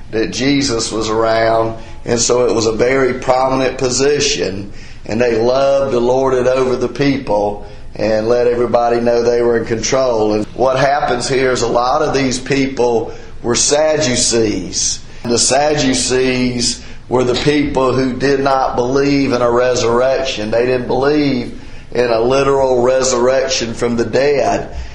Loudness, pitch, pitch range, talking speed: -14 LUFS, 125 Hz, 115-130 Hz, 155 wpm